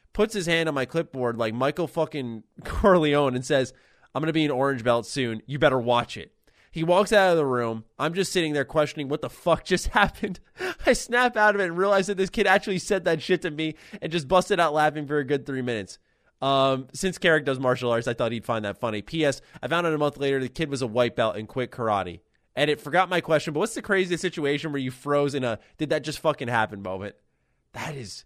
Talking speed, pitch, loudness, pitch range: 250 wpm, 145 Hz, -25 LUFS, 125-170 Hz